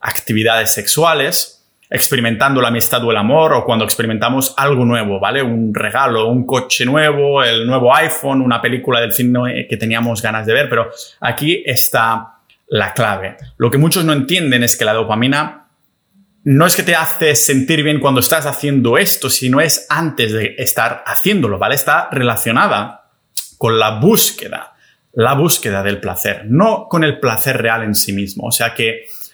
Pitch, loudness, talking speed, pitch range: 125 Hz, -13 LUFS, 170 wpm, 115-140 Hz